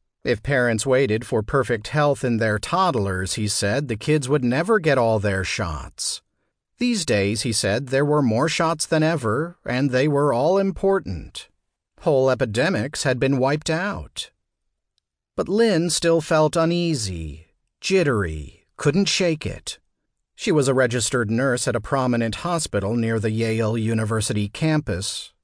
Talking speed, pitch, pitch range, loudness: 150 wpm, 130 Hz, 110-160 Hz, -21 LUFS